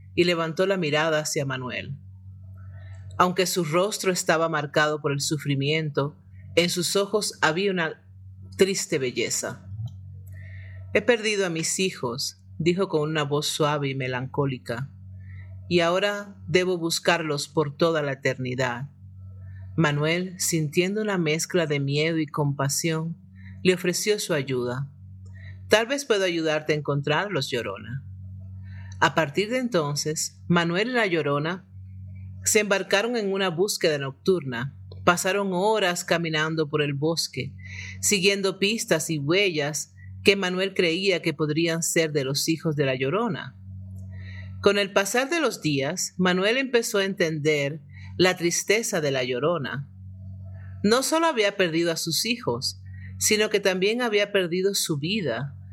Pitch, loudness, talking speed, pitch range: 155 Hz, -24 LUFS, 135 wpm, 120-185 Hz